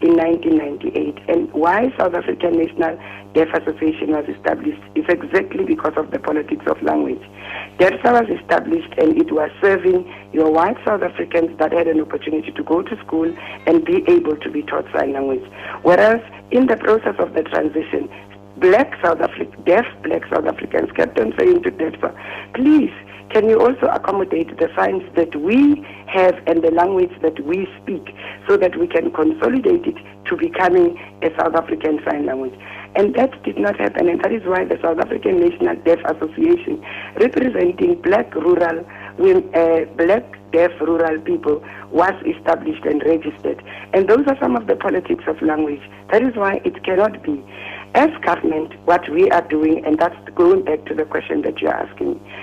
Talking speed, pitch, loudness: 175 wpm, 175 Hz, -18 LUFS